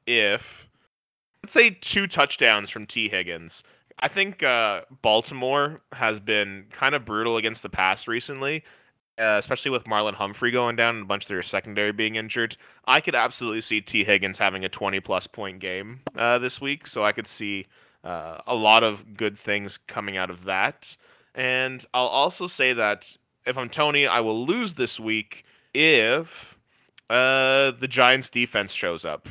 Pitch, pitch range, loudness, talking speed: 115 Hz, 105-130 Hz, -23 LUFS, 175 wpm